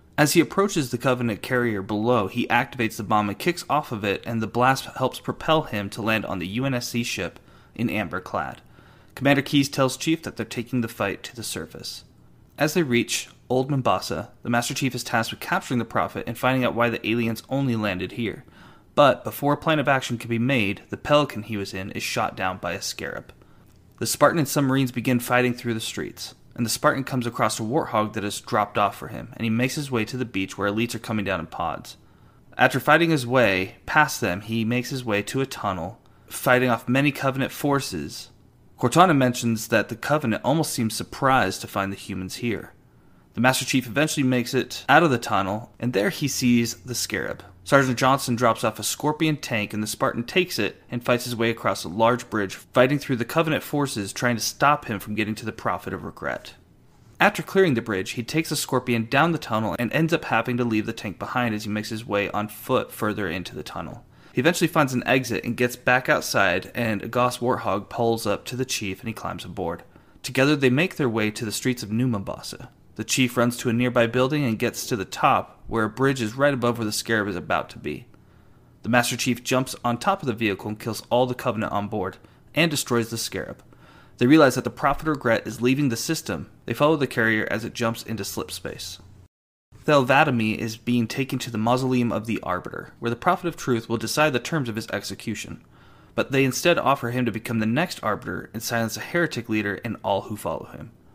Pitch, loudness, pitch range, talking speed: 120 Hz, -24 LUFS, 110-130 Hz, 225 wpm